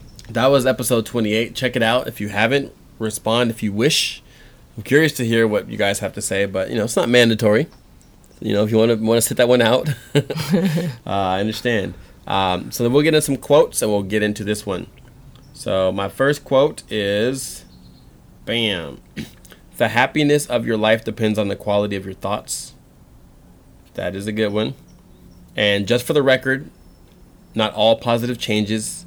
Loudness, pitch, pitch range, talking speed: -19 LUFS, 115 Hz, 105-125 Hz, 190 wpm